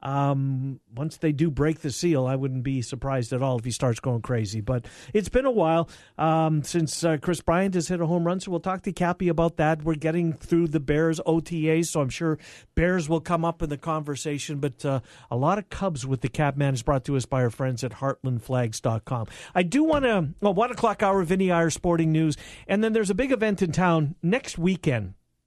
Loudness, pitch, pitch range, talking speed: -25 LUFS, 160 Hz, 135-175 Hz, 230 wpm